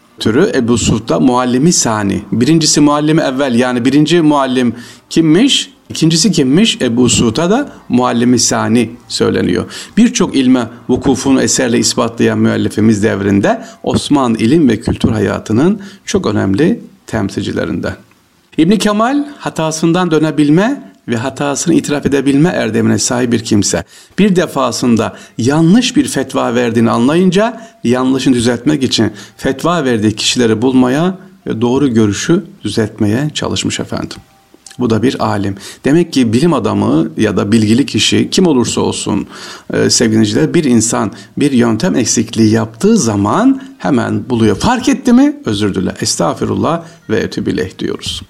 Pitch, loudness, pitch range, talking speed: 130 Hz, -12 LUFS, 115-170 Hz, 125 wpm